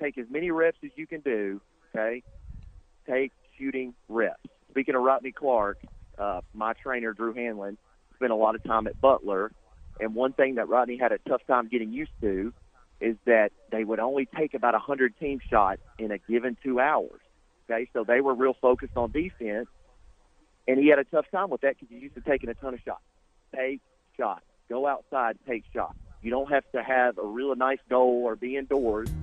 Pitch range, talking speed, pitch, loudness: 115-135 Hz, 200 wpm, 125 Hz, -27 LUFS